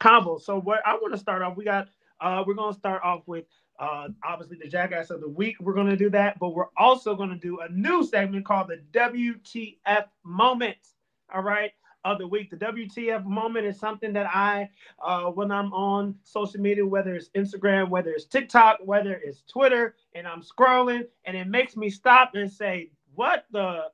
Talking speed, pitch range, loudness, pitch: 205 wpm, 185-220 Hz, -25 LUFS, 200 Hz